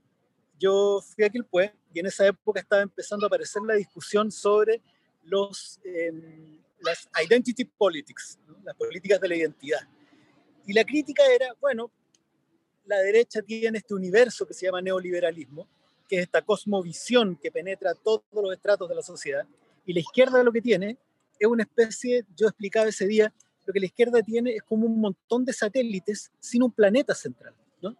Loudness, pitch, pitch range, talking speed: -25 LUFS, 210 Hz, 185-230 Hz, 175 wpm